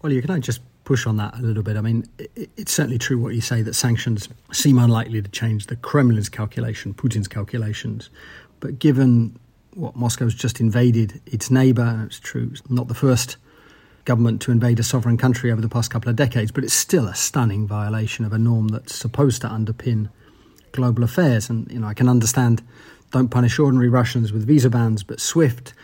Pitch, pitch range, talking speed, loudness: 120 Hz, 110-130 Hz, 200 wpm, -20 LUFS